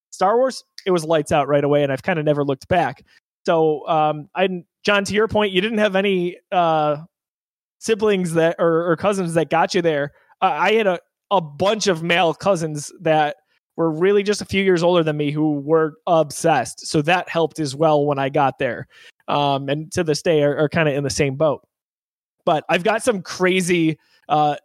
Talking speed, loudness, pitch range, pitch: 210 wpm, -19 LUFS, 150-190 Hz, 165 Hz